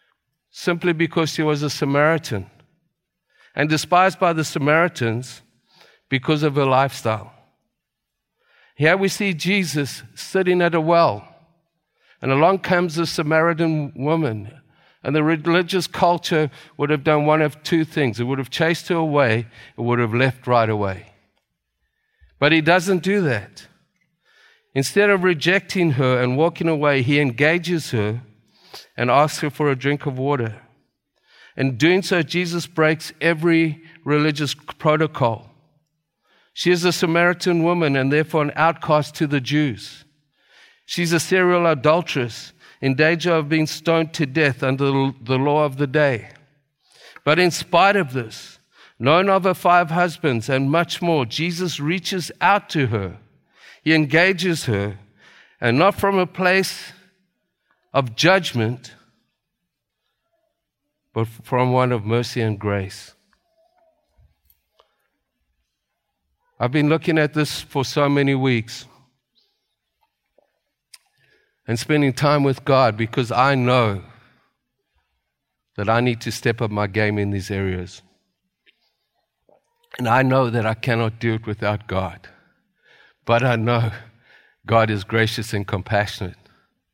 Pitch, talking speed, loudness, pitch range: 145 Hz, 135 wpm, -19 LUFS, 120-165 Hz